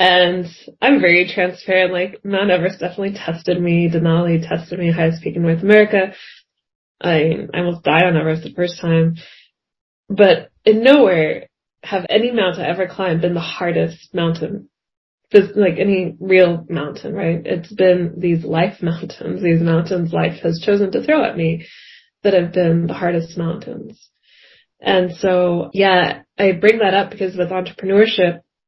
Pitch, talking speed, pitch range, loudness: 180 Hz, 155 wpm, 170-195 Hz, -16 LUFS